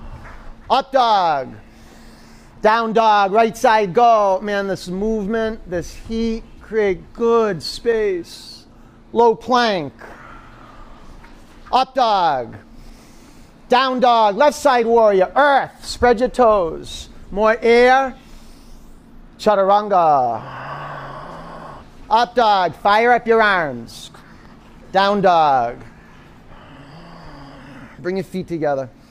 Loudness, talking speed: -16 LUFS, 90 wpm